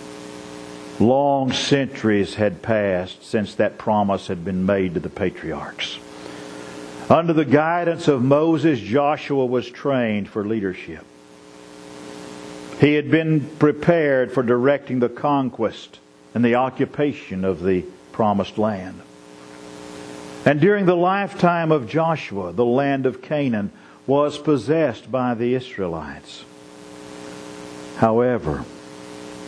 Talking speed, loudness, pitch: 110 wpm, -20 LUFS, 110 Hz